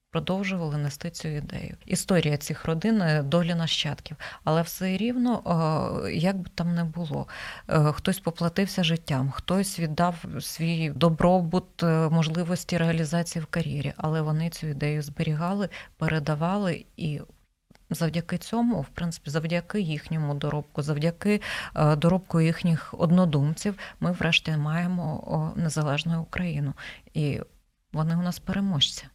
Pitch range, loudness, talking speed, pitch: 155-180 Hz, -27 LUFS, 115 wpm, 165 Hz